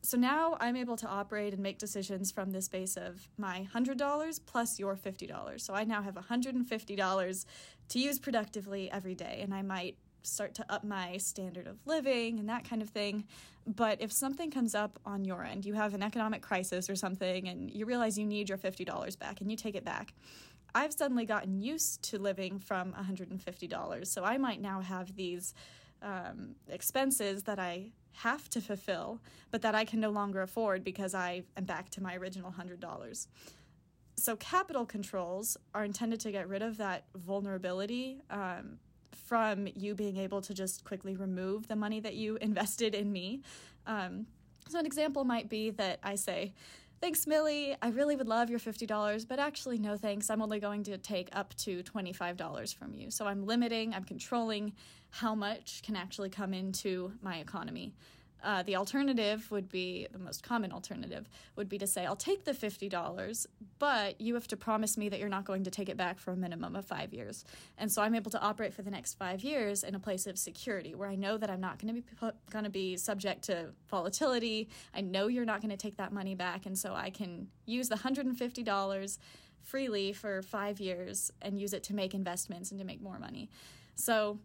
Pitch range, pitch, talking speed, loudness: 190-225 Hz, 205 Hz, 205 wpm, -36 LUFS